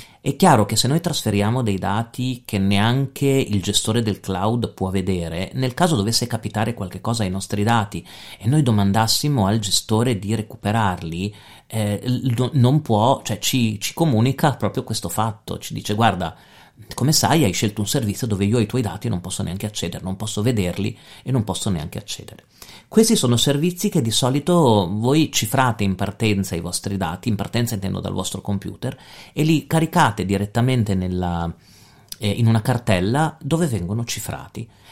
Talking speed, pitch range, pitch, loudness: 170 wpm, 100-130 Hz, 110 Hz, -20 LUFS